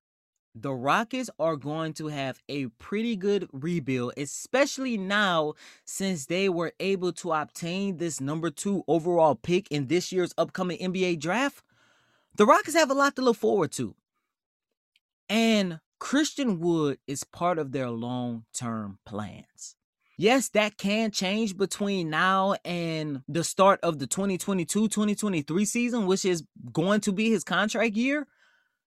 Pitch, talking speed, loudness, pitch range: 180 Hz, 145 wpm, -27 LUFS, 155-210 Hz